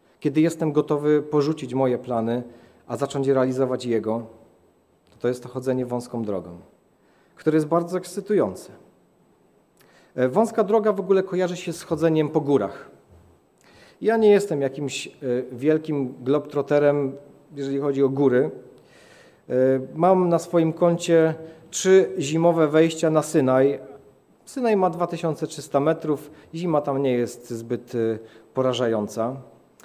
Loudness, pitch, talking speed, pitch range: -23 LUFS, 145 Hz, 120 wpm, 125-165 Hz